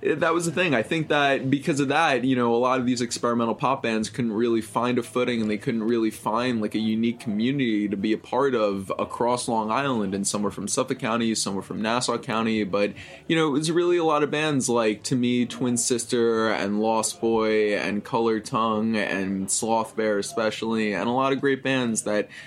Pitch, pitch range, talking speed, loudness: 115 Hz, 110-130 Hz, 225 wpm, -24 LUFS